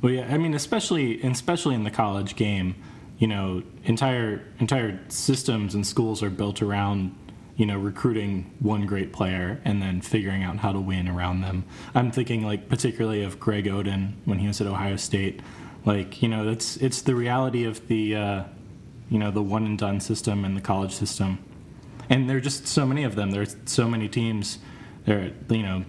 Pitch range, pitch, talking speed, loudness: 100-125 Hz, 105 Hz, 195 wpm, -26 LUFS